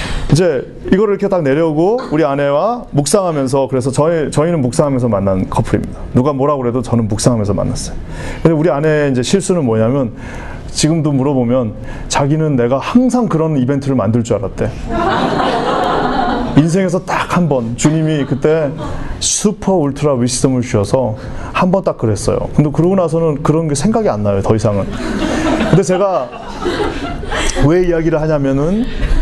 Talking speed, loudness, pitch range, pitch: 345 characters per minute, -14 LUFS, 125-165 Hz, 145 Hz